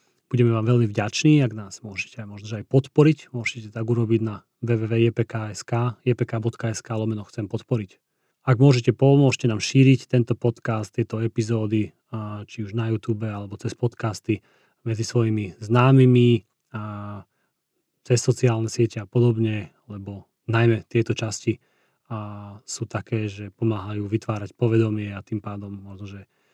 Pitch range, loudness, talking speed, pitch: 105-120 Hz, -23 LUFS, 130 wpm, 115 Hz